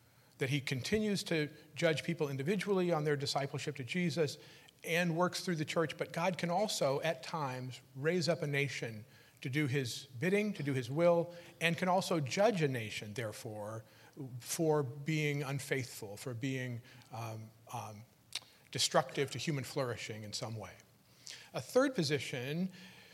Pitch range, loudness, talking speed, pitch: 125-170 Hz, -36 LUFS, 155 wpm, 145 Hz